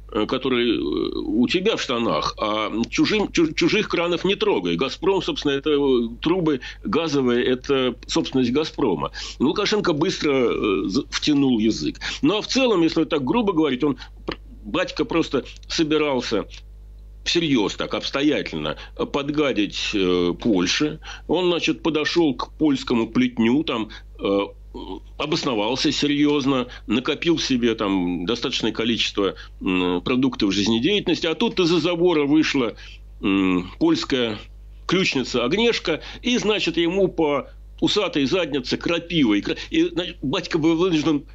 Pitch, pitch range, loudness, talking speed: 160 Hz, 125-200 Hz, -21 LUFS, 115 wpm